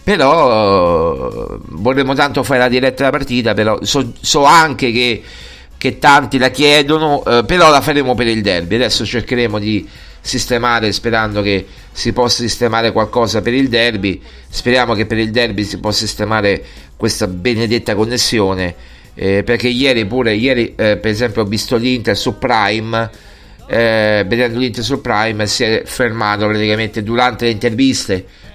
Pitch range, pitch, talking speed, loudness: 105-125 Hz, 115 Hz, 155 wpm, -13 LUFS